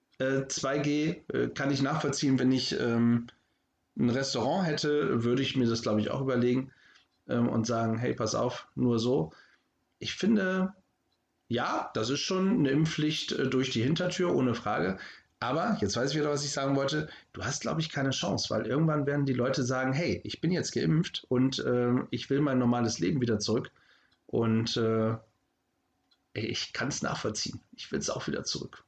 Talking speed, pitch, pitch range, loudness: 180 wpm, 135 Hz, 120-150 Hz, -30 LUFS